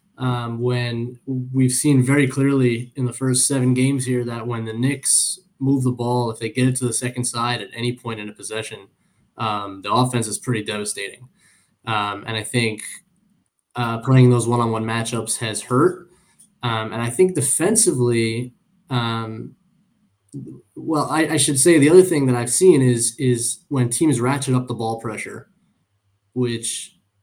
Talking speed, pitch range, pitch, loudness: 170 wpm, 115-135 Hz, 120 Hz, -20 LUFS